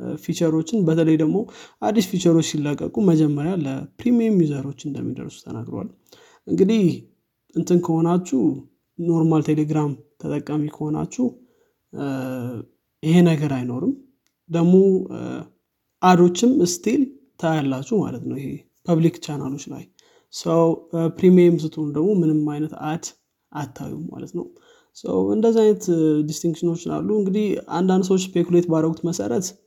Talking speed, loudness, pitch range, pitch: 105 wpm, -21 LUFS, 150-190 Hz, 165 Hz